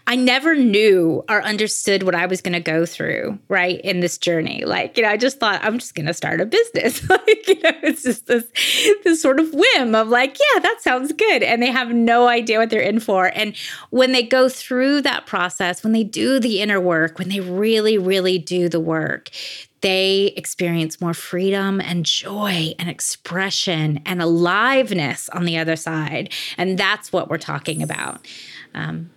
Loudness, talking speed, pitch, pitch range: -18 LUFS, 195 wpm, 205 Hz, 180-250 Hz